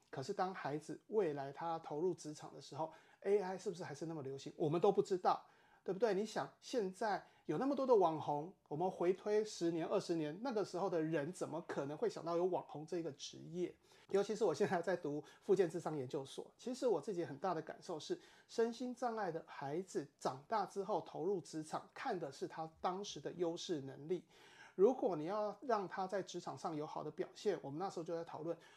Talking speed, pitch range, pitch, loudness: 315 characters per minute, 160-205 Hz, 180 Hz, -41 LUFS